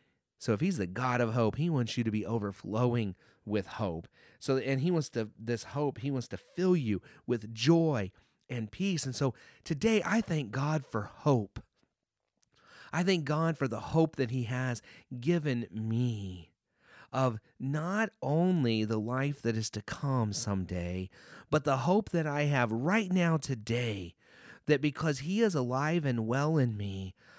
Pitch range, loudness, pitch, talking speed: 110-155 Hz, -32 LUFS, 130 Hz, 170 wpm